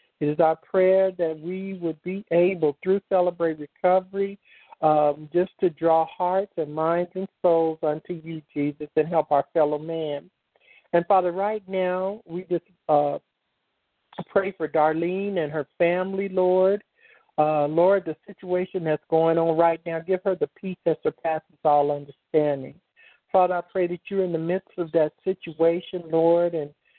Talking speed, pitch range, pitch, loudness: 160 wpm, 155-185 Hz, 170 Hz, -24 LUFS